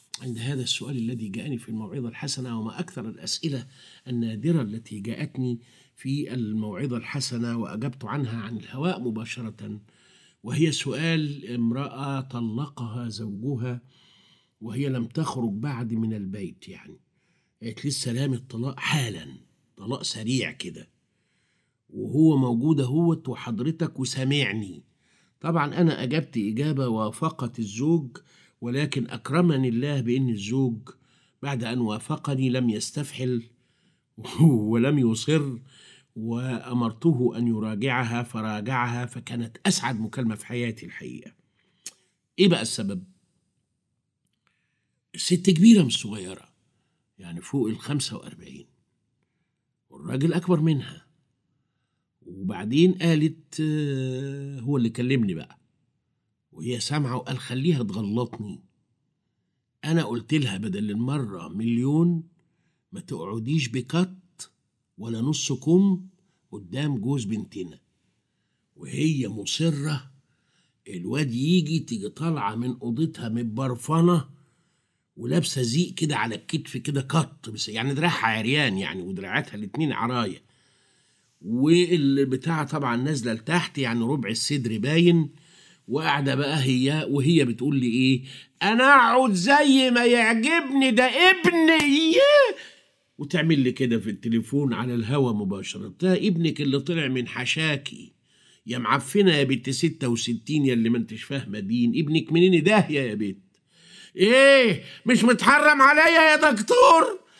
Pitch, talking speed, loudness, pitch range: 135 Hz, 110 wpm, -24 LUFS, 120-165 Hz